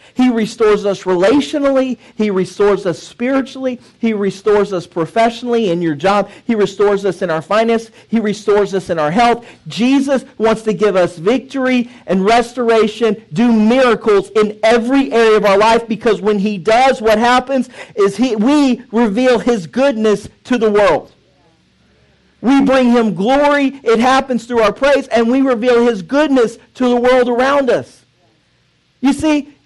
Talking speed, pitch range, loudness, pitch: 160 wpm, 210-255 Hz, -14 LUFS, 230 Hz